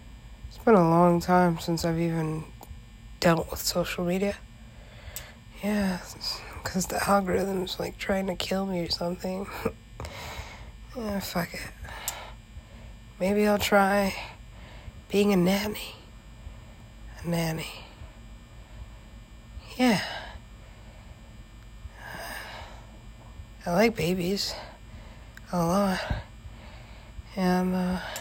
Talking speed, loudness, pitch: 90 wpm, -27 LUFS, 175 Hz